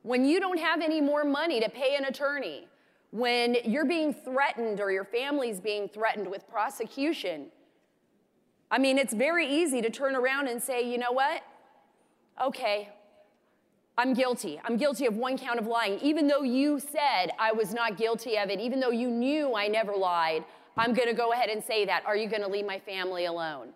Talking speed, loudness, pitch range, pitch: 190 wpm, -29 LUFS, 215-280 Hz, 245 Hz